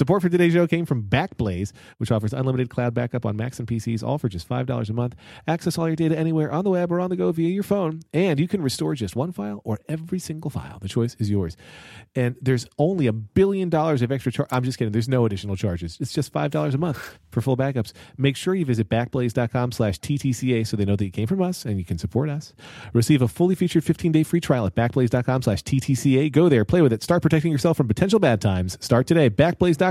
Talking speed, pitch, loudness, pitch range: 245 wpm, 130 Hz, -23 LUFS, 115-160 Hz